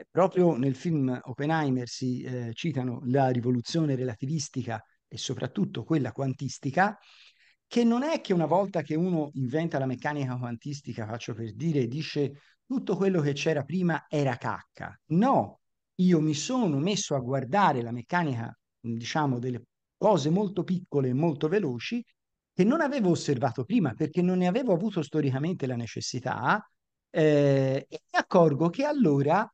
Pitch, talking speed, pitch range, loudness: 150 Hz, 150 wpm, 130-180 Hz, -28 LUFS